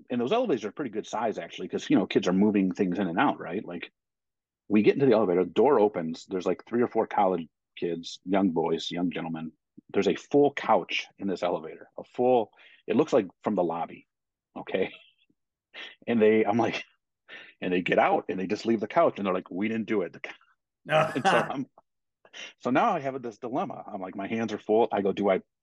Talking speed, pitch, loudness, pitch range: 220 wpm, 105 Hz, -27 LUFS, 90-115 Hz